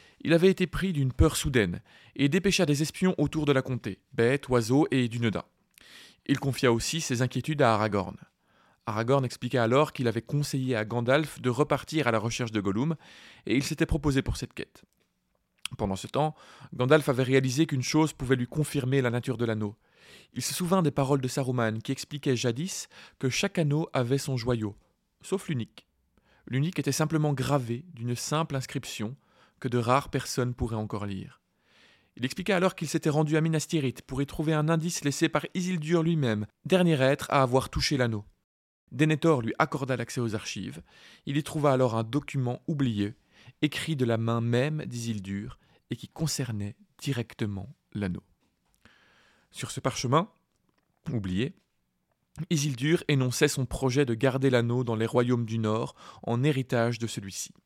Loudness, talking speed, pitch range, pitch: -28 LUFS, 170 wpm, 120-155 Hz, 135 Hz